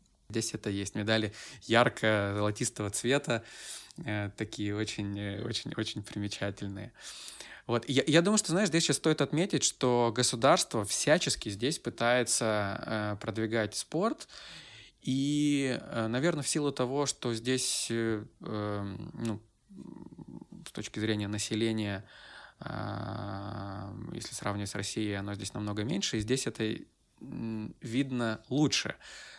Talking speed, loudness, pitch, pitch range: 115 wpm, -31 LUFS, 110 Hz, 105-130 Hz